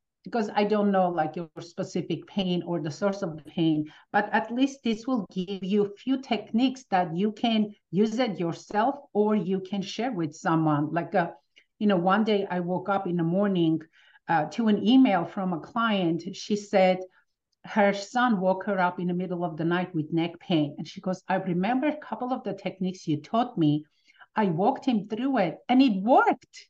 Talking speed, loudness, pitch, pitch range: 205 wpm, -27 LUFS, 190 Hz, 175-215 Hz